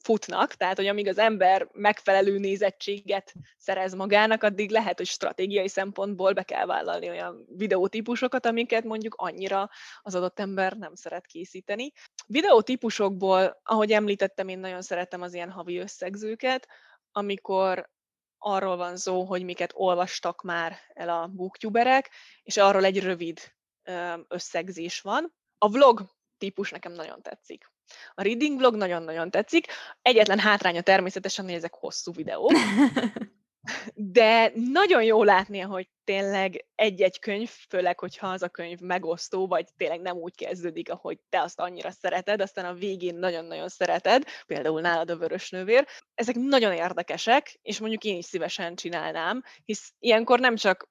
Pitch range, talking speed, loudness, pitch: 180-220 Hz, 145 wpm, -26 LUFS, 195 Hz